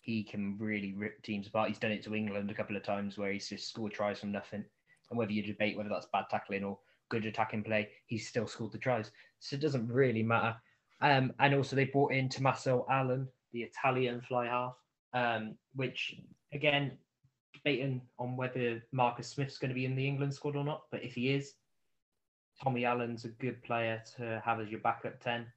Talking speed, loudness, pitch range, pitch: 205 wpm, -35 LUFS, 110-130 Hz, 120 Hz